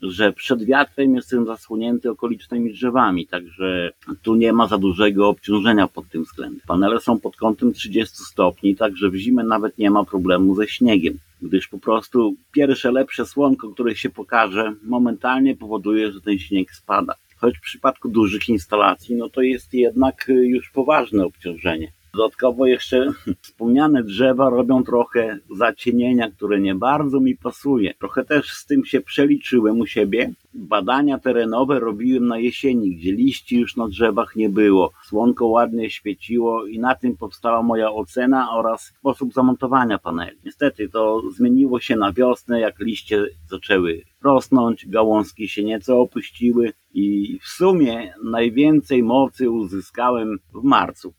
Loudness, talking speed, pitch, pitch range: -19 LUFS, 150 wpm, 115 Hz, 105-130 Hz